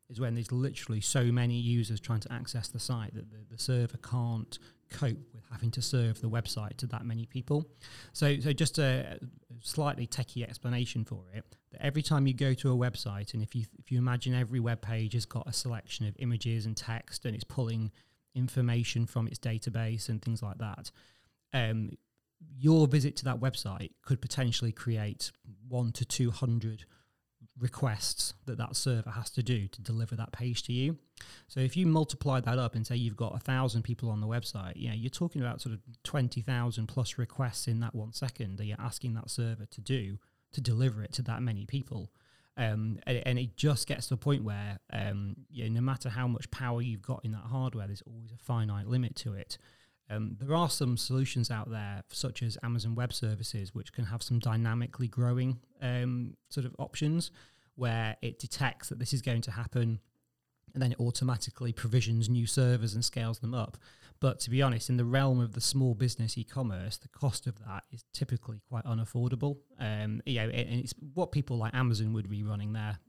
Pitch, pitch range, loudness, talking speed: 120 Hz, 115-130 Hz, -33 LUFS, 205 wpm